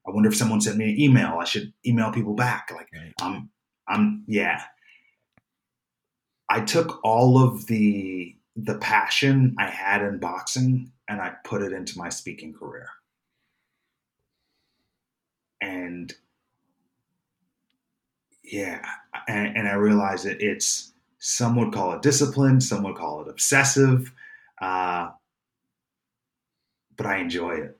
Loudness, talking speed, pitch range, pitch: -23 LUFS, 125 wpm, 100-130 Hz, 115 Hz